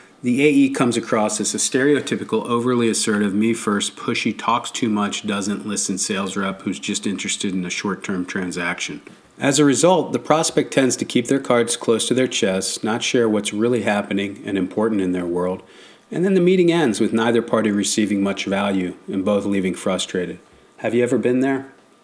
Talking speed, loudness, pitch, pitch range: 195 wpm, -20 LUFS, 110 Hz, 100-125 Hz